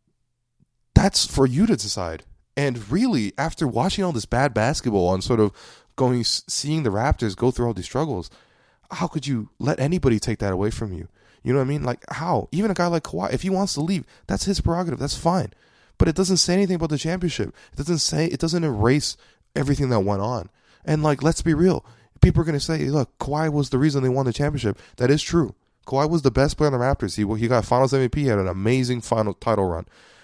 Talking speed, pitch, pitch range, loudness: 230 wpm, 135 Hz, 115-160 Hz, -22 LUFS